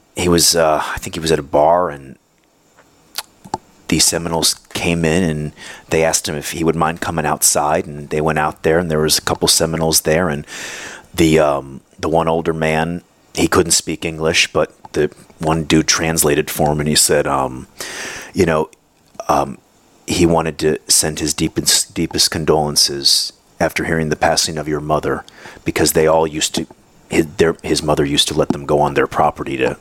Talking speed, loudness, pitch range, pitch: 185 wpm, -16 LUFS, 75-80 Hz, 80 Hz